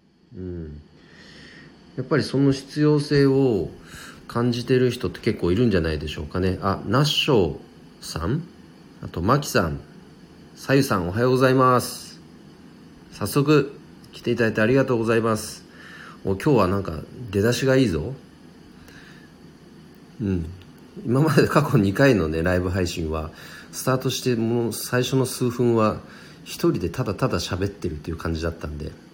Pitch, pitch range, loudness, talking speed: 115 Hz, 90-130 Hz, -22 LUFS, 300 characters per minute